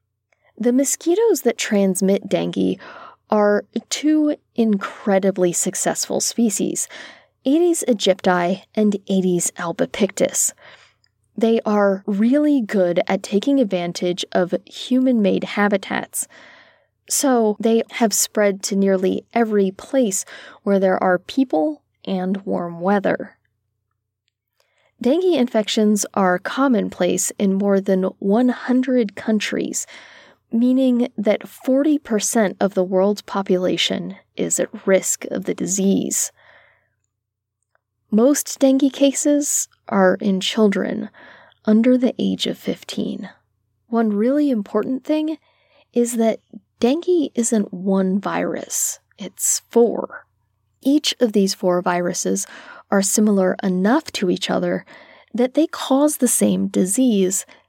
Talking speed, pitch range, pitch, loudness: 105 wpm, 190-250 Hz, 210 Hz, -19 LUFS